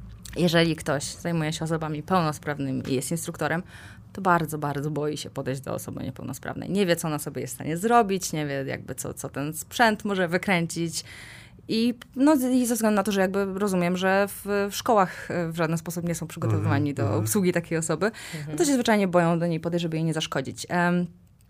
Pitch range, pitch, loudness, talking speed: 150-190 Hz, 170 Hz, -26 LUFS, 205 wpm